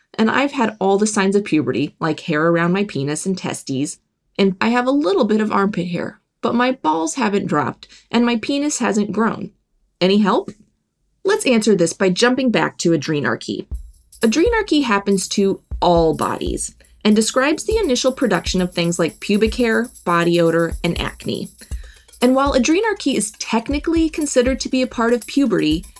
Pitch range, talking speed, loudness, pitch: 175-255 Hz, 175 wpm, -18 LUFS, 210 Hz